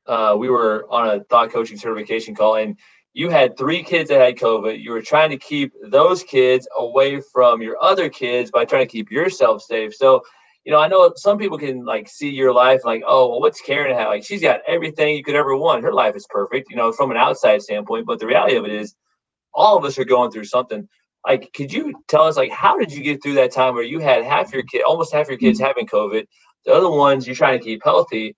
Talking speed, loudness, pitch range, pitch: 245 wpm, -17 LUFS, 115-155 Hz, 130 Hz